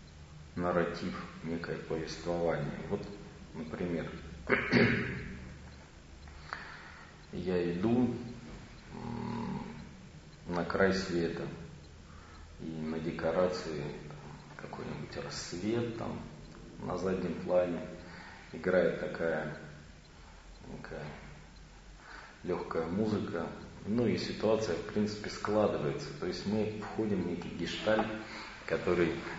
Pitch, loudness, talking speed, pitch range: 85 Hz, -35 LUFS, 80 wpm, 80-95 Hz